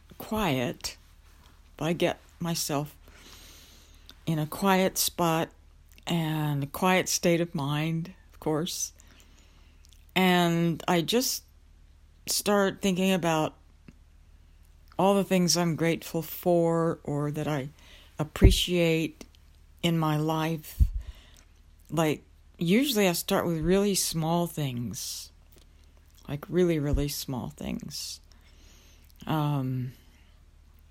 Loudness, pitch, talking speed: -28 LUFS, 145 Hz, 95 wpm